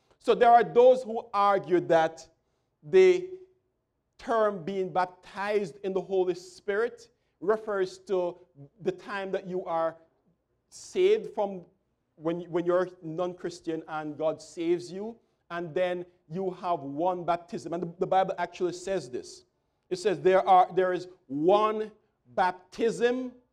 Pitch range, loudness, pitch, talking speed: 175-215 Hz, -28 LUFS, 185 Hz, 135 wpm